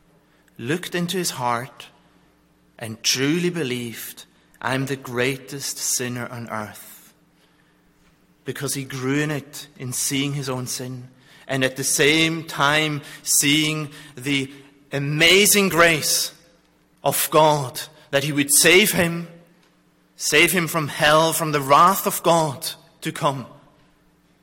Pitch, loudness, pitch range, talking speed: 145 Hz, -19 LUFS, 130-160 Hz, 125 wpm